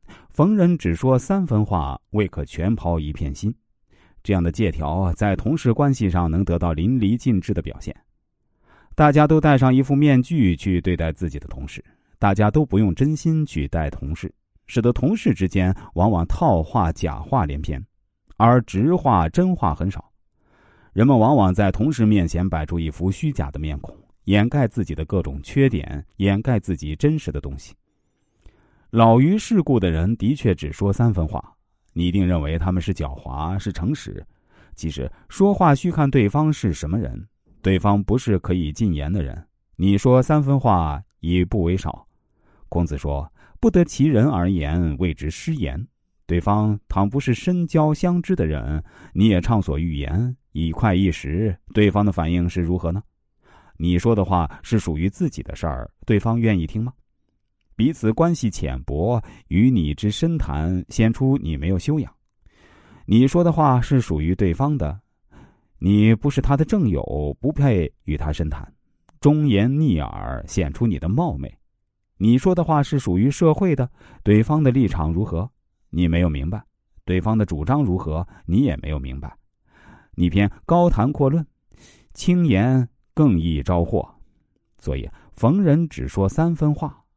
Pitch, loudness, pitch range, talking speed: 100 Hz, -20 LUFS, 85-130 Hz, 235 characters per minute